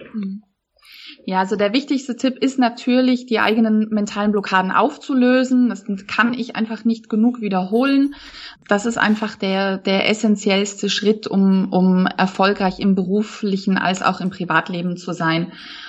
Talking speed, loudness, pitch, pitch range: 140 wpm, -18 LUFS, 210 Hz, 195-235 Hz